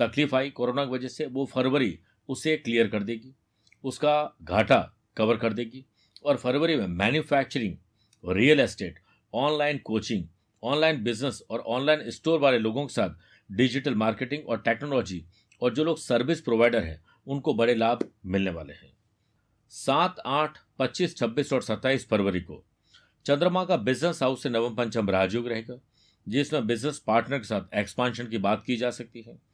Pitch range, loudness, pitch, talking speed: 110-140 Hz, -27 LUFS, 120 Hz, 160 wpm